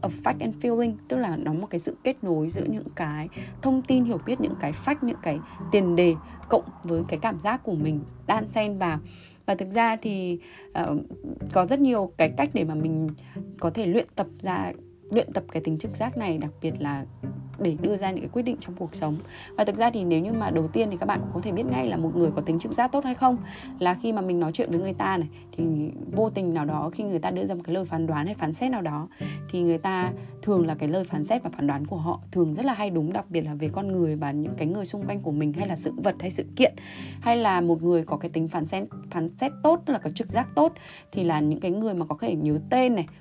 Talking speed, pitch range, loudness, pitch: 275 wpm, 155-210 Hz, -26 LUFS, 170 Hz